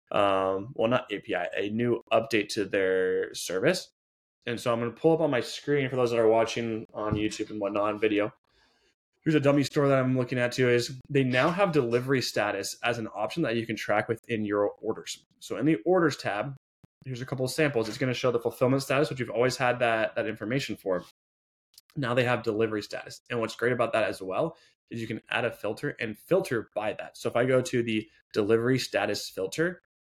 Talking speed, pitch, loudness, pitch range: 220 wpm, 120 Hz, -28 LUFS, 110-140 Hz